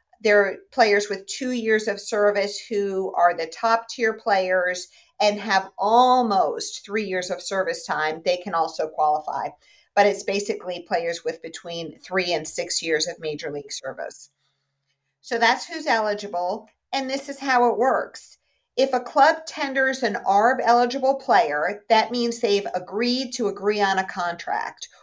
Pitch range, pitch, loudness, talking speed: 180-245 Hz, 205 Hz, -23 LUFS, 160 wpm